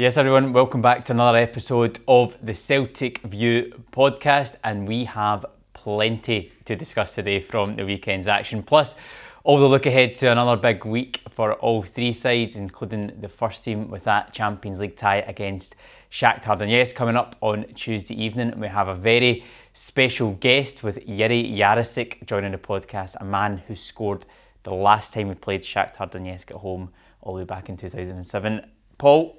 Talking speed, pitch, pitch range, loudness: 180 wpm, 110 Hz, 100-120 Hz, -21 LUFS